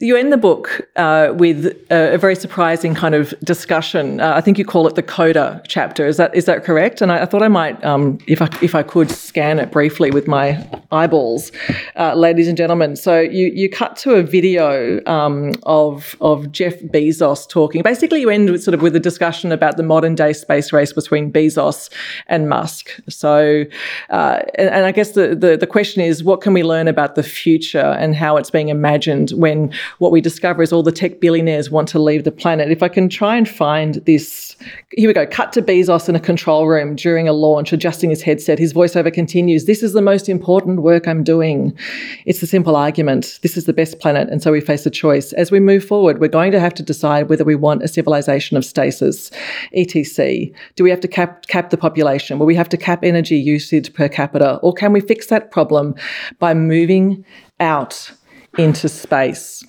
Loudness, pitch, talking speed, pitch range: -15 LUFS, 165 Hz, 215 wpm, 155-180 Hz